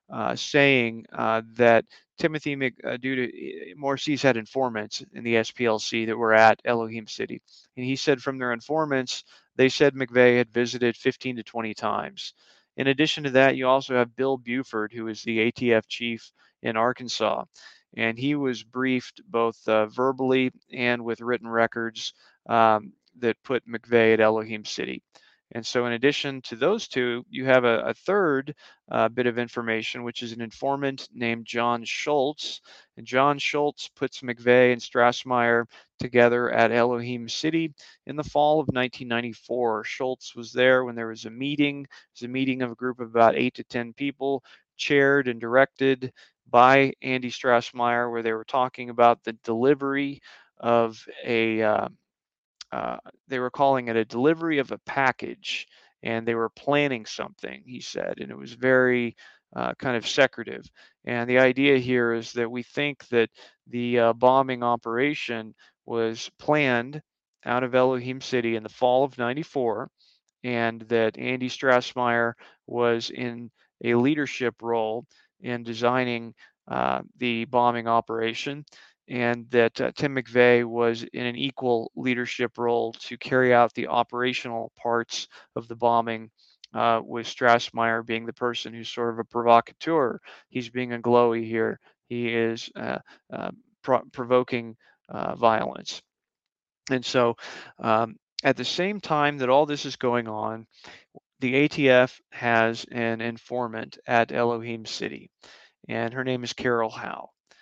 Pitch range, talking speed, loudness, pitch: 115-130 Hz, 155 wpm, -25 LUFS, 120 Hz